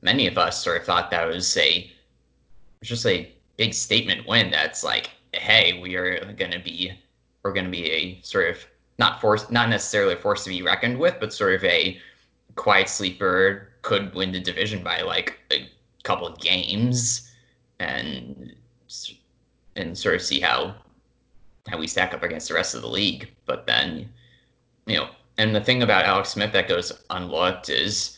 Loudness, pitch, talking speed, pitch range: -22 LUFS, 105 Hz, 180 wpm, 90-120 Hz